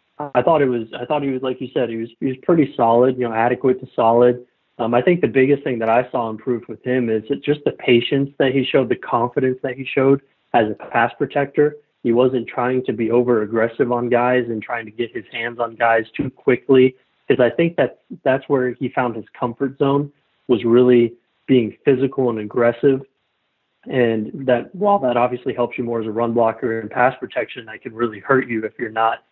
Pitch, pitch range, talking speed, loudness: 125 Hz, 115-135 Hz, 225 wpm, -19 LUFS